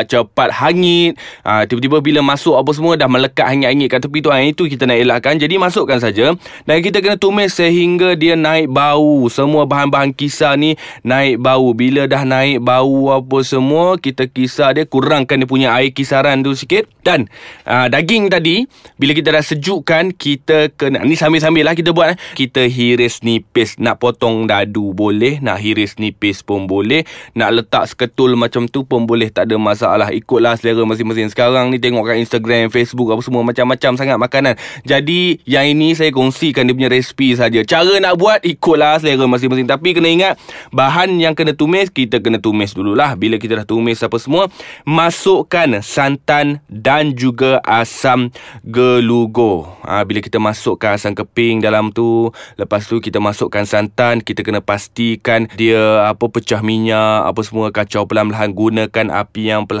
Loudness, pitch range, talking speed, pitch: -13 LUFS, 115-150 Hz, 170 wpm, 130 Hz